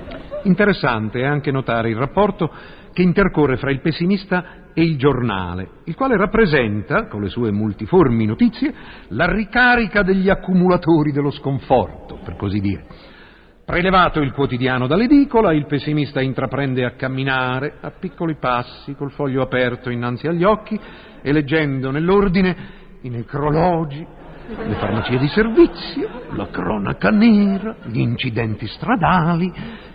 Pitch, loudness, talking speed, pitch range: 150 Hz, -18 LUFS, 130 wpm, 130-190 Hz